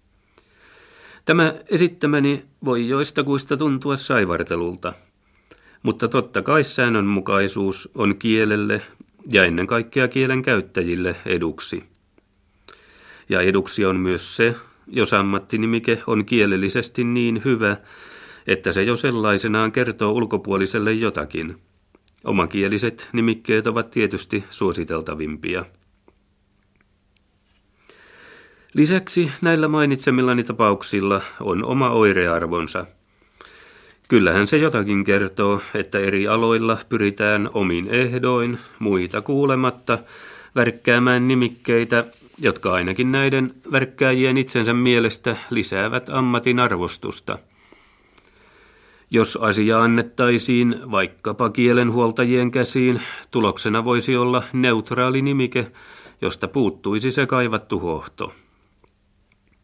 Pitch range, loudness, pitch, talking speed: 100-125 Hz, -20 LUFS, 115 Hz, 90 wpm